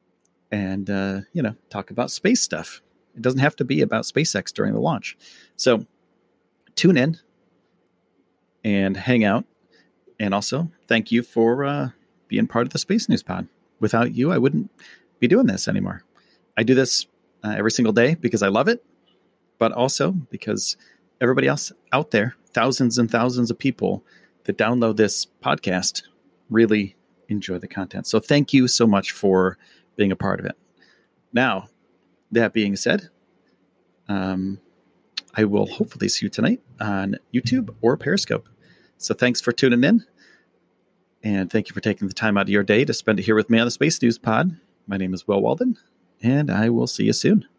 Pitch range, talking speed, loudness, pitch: 100-130 Hz, 175 wpm, -21 LUFS, 115 Hz